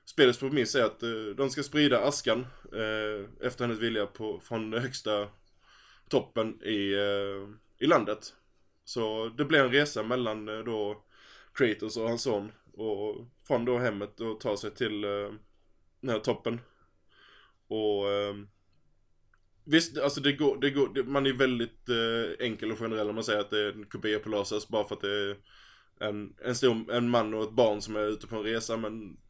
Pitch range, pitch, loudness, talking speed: 105-120 Hz, 110 Hz, -30 LUFS, 185 wpm